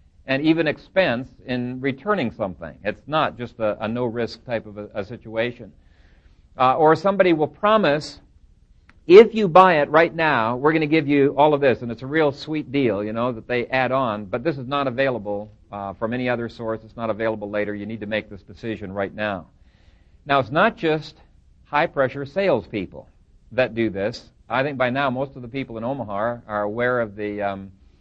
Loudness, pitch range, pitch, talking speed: -21 LUFS, 105-140 Hz, 120 Hz, 205 wpm